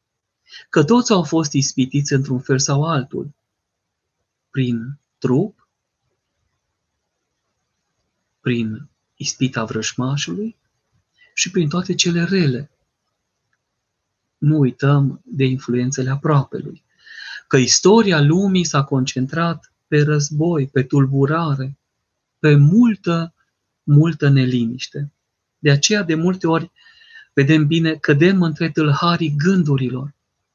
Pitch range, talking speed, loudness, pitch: 130-165 Hz, 95 wpm, -17 LUFS, 145 Hz